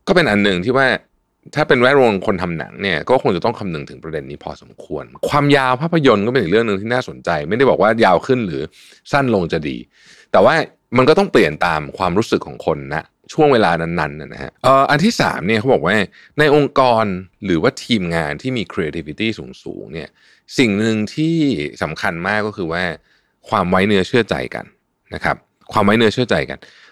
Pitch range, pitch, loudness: 90-135 Hz, 110 Hz, -16 LUFS